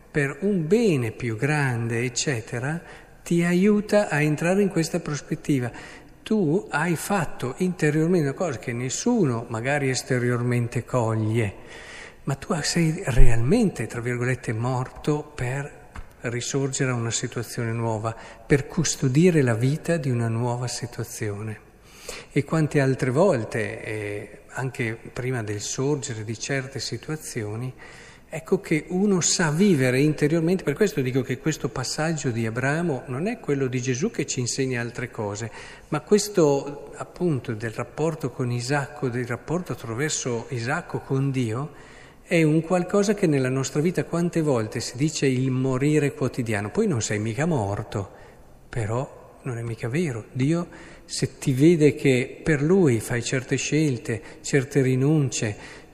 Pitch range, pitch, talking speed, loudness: 120-155 Hz, 135 Hz, 140 wpm, -24 LUFS